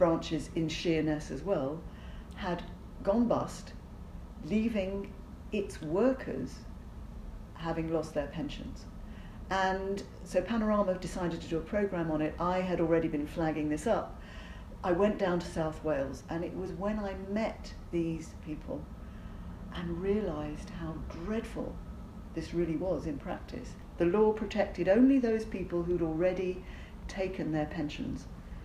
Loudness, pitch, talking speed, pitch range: -33 LUFS, 175 Hz, 140 wpm, 160-195 Hz